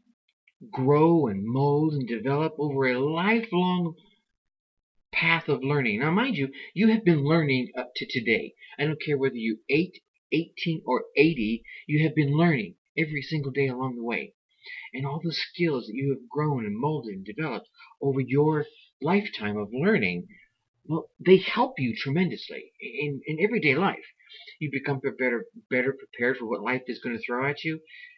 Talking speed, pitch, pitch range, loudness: 170 wpm, 145 Hz, 130-170 Hz, -26 LUFS